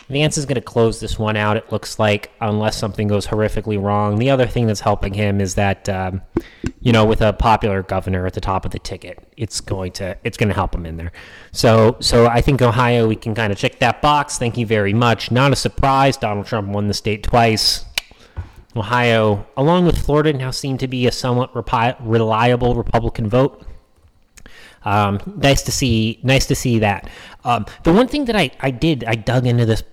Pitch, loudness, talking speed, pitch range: 115 Hz, -17 LUFS, 215 wpm, 105-125 Hz